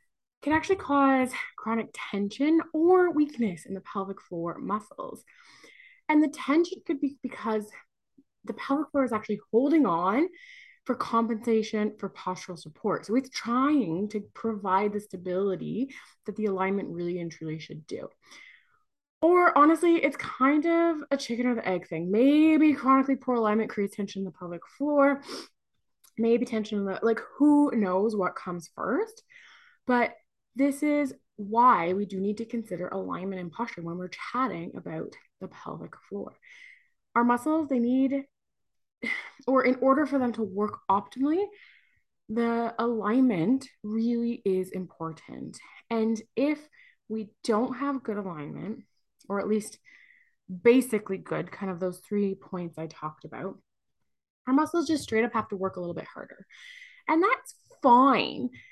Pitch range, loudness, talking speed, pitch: 200-290 Hz, -27 LUFS, 150 wpm, 235 Hz